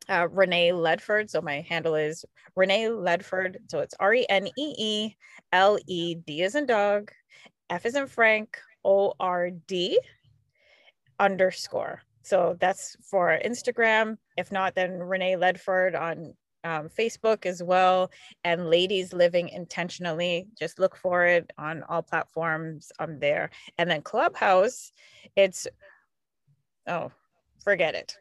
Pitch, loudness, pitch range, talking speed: 185 Hz, -26 LUFS, 170-200 Hz, 135 wpm